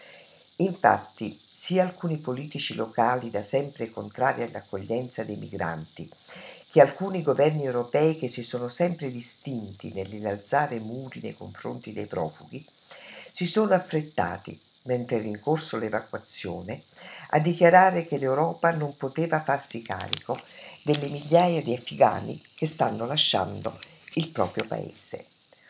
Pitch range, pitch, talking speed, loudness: 115-155 Hz, 130 Hz, 120 wpm, -24 LUFS